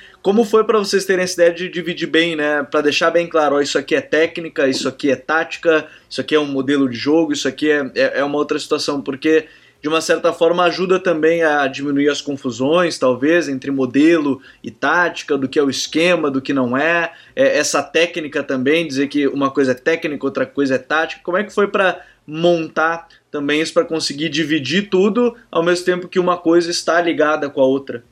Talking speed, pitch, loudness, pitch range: 215 wpm, 160 Hz, -17 LUFS, 140-170 Hz